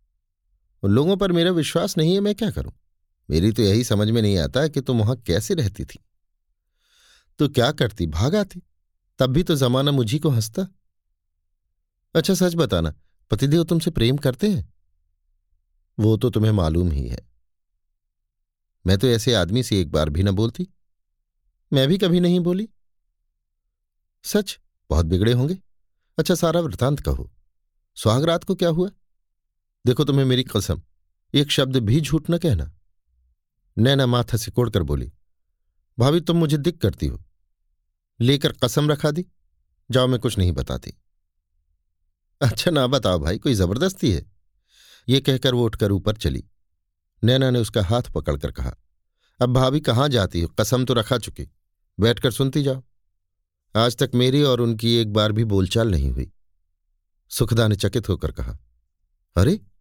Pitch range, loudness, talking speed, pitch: 80-135 Hz, -21 LUFS, 155 wpm, 110 Hz